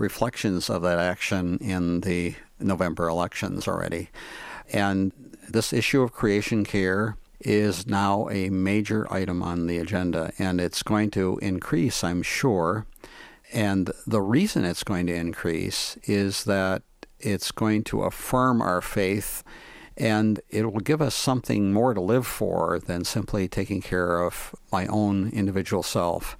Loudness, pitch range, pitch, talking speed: -25 LUFS, 90-105 Hz, 100 Hz, 145 wpm